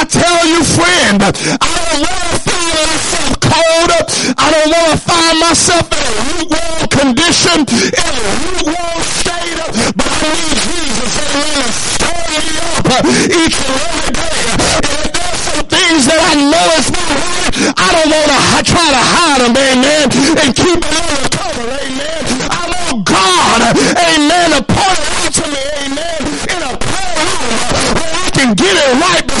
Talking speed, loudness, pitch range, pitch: 175 wpm, -10 LUFS, 285-335 Hz, 315 Hz